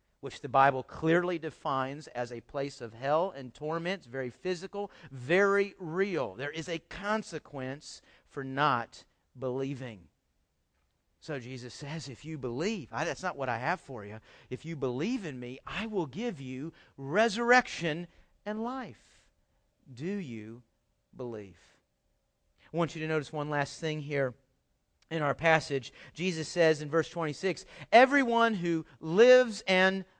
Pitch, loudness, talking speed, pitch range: 150 Hz, -31 LUFS, 145 wpm, 125-180 Hz